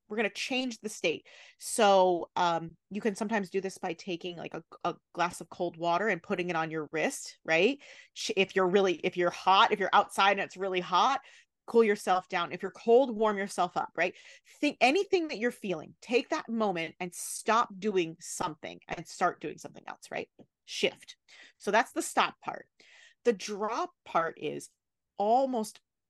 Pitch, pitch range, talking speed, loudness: 200 Hz, 180-235 Hz, 185 wpm, -30 LUFS